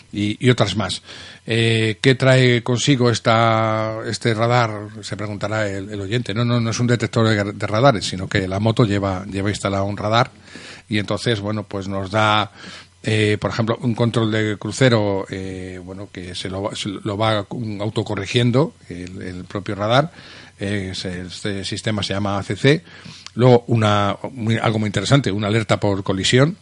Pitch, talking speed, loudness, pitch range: 105 Hz, 170 wpm, -19 LUFS, 100-115 Hz